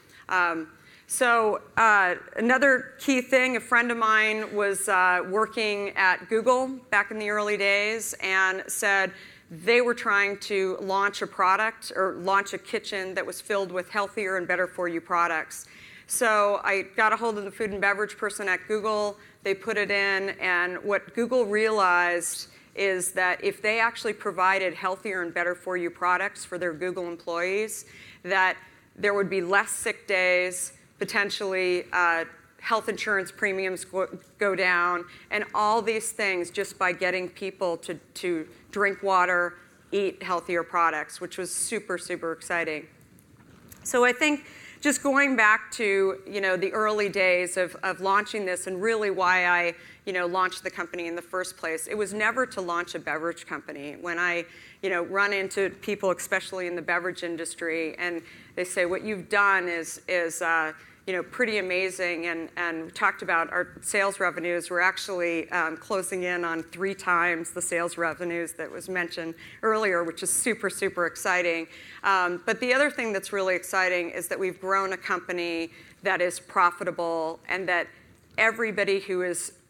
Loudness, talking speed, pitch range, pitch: -26 LUFS, 170 wpm, 175-205 Hz, 185 Hz